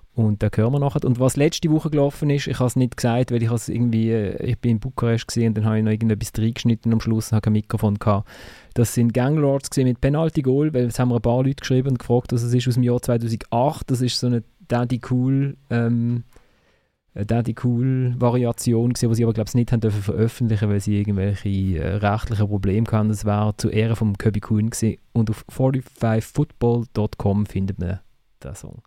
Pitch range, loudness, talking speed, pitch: 110-125 Hz, -21 LUFS, 210 wpm, 115 Hz